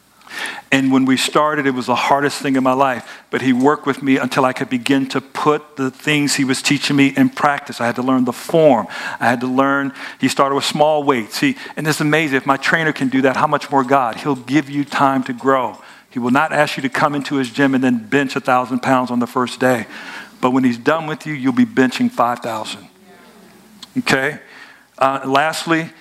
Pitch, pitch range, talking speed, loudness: 135 Hz, 130-150 Hz, 230 wpm, -17 LUFS